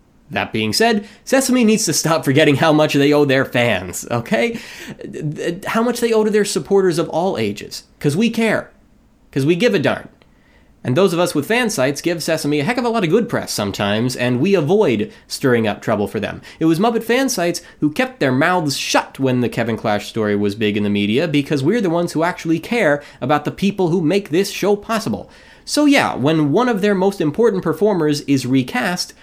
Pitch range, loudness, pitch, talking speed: 140-210 Hz, -17 LUFS, 165 Hz, 215 wpm